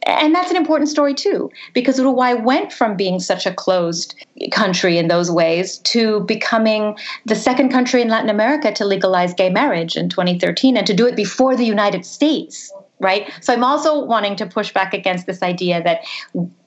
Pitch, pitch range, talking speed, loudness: 215 Hz, 190-265 Hz, 185 wpm, -17 LUFS